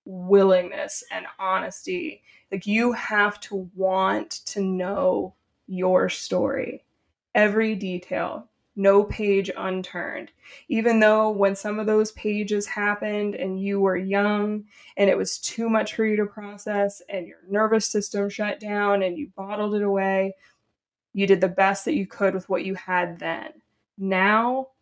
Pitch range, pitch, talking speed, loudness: 190-215 Hz, 200 Hz, 150 wpm, -24 LUFS